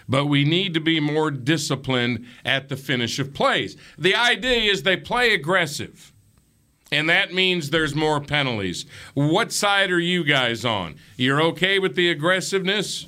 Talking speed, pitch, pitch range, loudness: 160 wpm, 155 Hz, 135-185 Hz, -21 LUFS